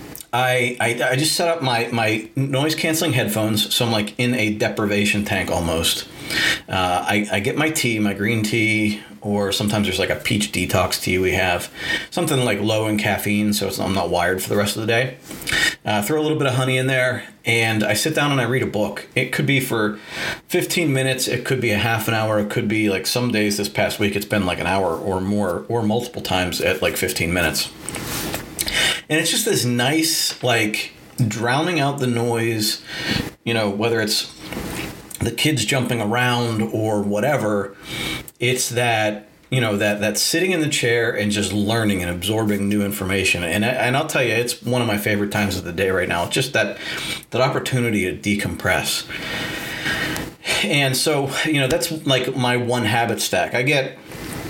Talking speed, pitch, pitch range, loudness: 200 wpm, 110 Hz, 105-125 Hz, -20 LUFS